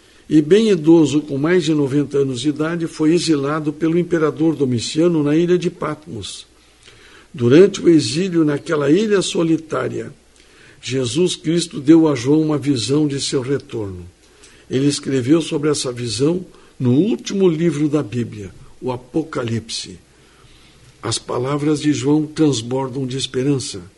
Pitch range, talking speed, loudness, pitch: 135-165 Hz, 135 wpm, -17 LUFS, 150 Hz